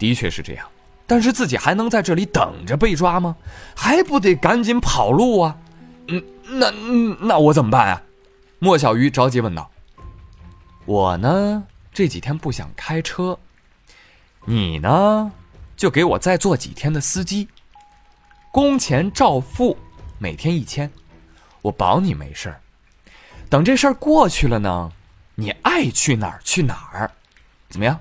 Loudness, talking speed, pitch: -18 LUFS, 205 characters per minute, 155 Hz